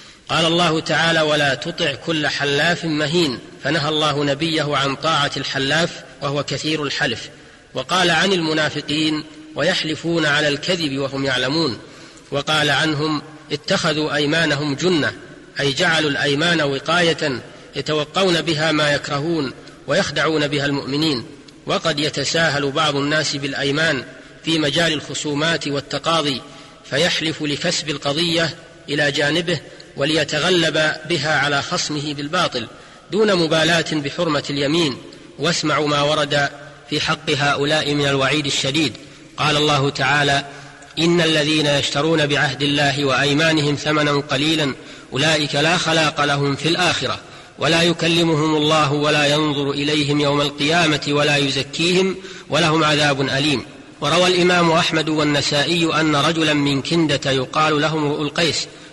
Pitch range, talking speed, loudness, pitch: 145-160 Hz, 115 wpm, -18 LUFS, 150 Hz